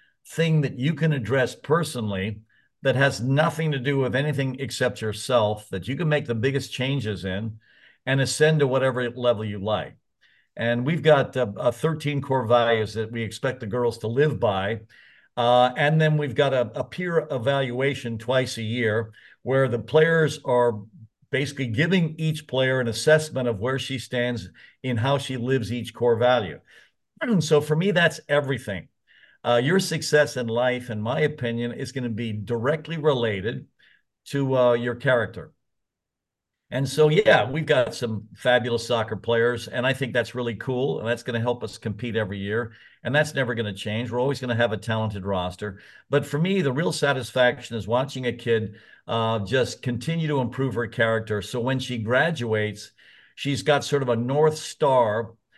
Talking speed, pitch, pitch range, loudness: 180 wpm, 125 Hz, 115-140 Hz, -24 LUFS